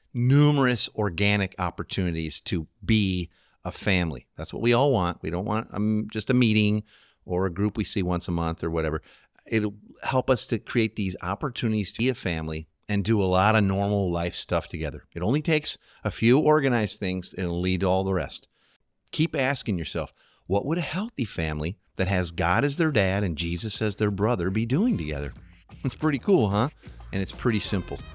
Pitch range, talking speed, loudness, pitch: 90-115 Hz, 200 wpm, -26 LUFS, 100 Hz